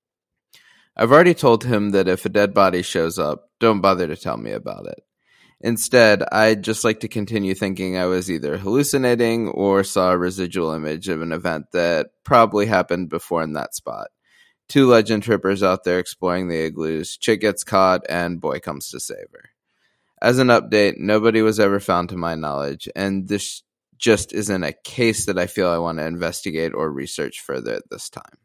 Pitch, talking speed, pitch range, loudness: 95 Hz, 190 wpm, 90-110 Hz, -19 LUFS